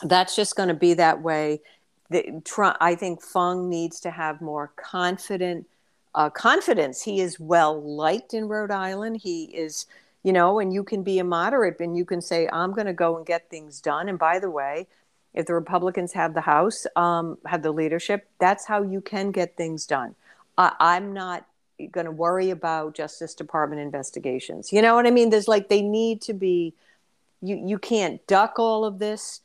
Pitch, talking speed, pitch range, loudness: 175 Hz, 195 wpm, 165-200 Hz, -24 LUFS